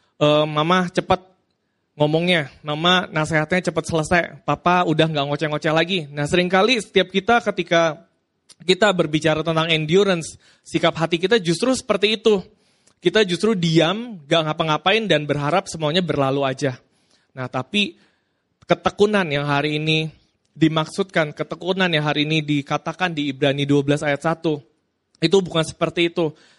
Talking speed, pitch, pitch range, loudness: 130 wpm, 165 Hz, 150-185 Hz, -20 LUFS